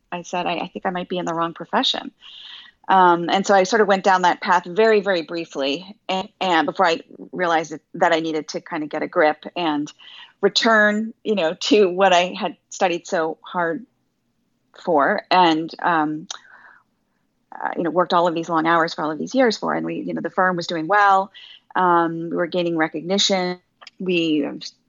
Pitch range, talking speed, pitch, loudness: 165-195 Hz, 205 wpm, 175 Hz, -20 LUFS